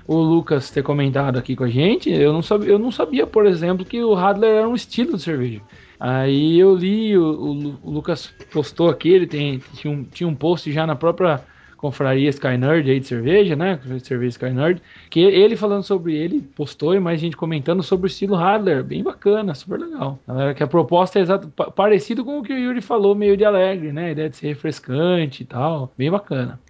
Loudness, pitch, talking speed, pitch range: -19 LUFS, 165 Hz, 215 wpm, 145-195 Hz